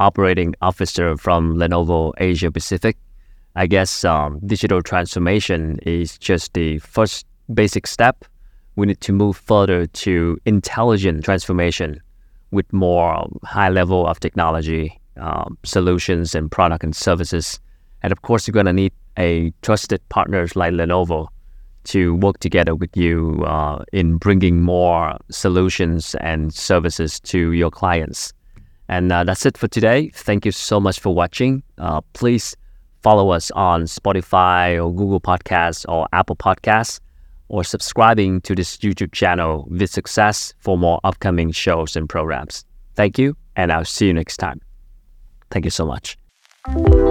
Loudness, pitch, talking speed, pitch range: -18 LUFS, 90 Hz, 145 wpm, 85-100 Hz